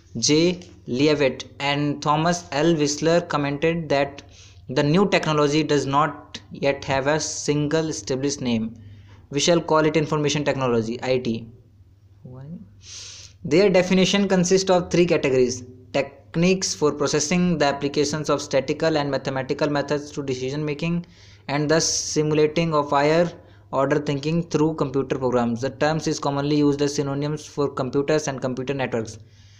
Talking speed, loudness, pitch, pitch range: 135 wpm, -22 LUFS, 145 Hz, 130-155 Hz